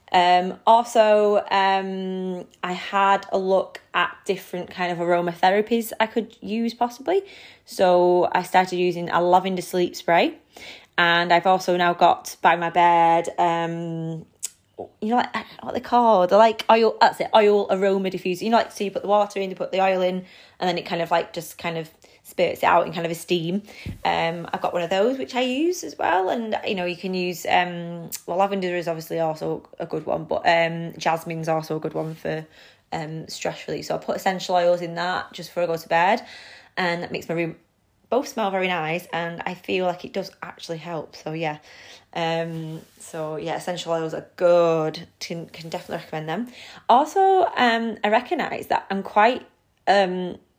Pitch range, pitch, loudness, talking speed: 170-200 Hz, 180 Hz, -22 LUFS, 195 wpm